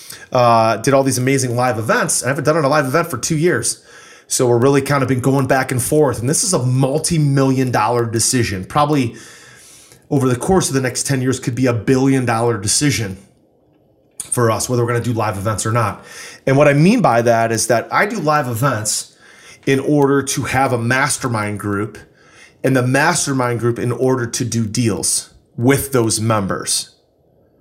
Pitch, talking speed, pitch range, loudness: 130 Hz, 200 wpm, 115-140 Hz, -16 LUFS